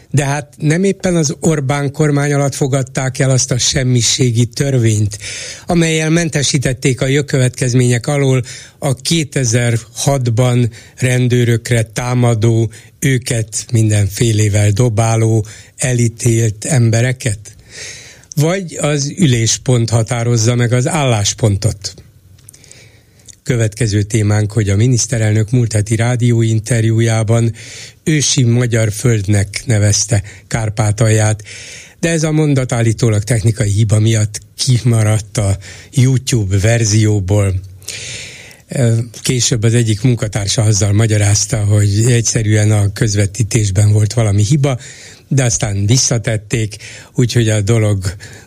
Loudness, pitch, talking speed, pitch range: -14 LUFS, 115 Hz, 100 wpm, 110-130 Hz